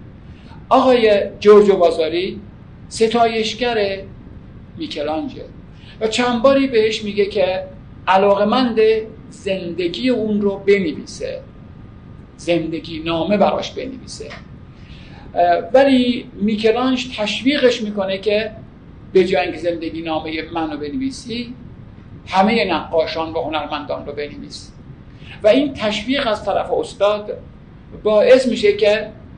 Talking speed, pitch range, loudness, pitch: 95 wpm, 170-230 Hz, -17 LUFS, 205 Hz